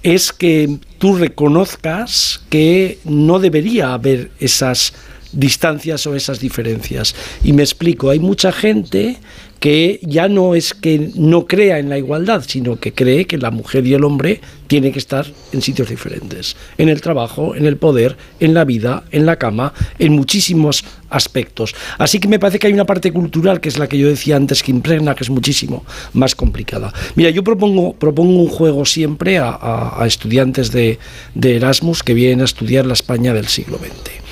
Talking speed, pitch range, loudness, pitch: 185 wpm, 130-170 Hz, -14 LUFS, 145 Hz